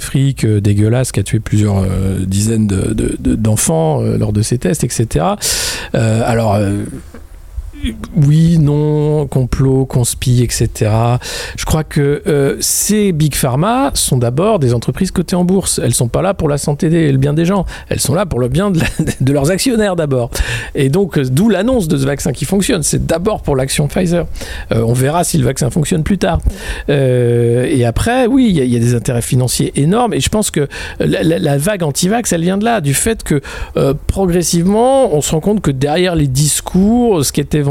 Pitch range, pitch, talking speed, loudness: 120-175 Hz, 145 Hz, 210 wpm, -13 LUFS